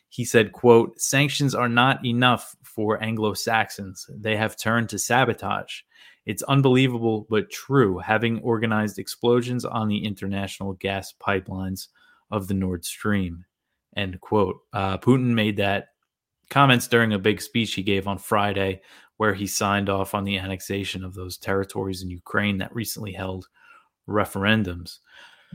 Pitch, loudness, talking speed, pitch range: 105 Hz, -23 LUFS, 145 wpm, 95-115 Hz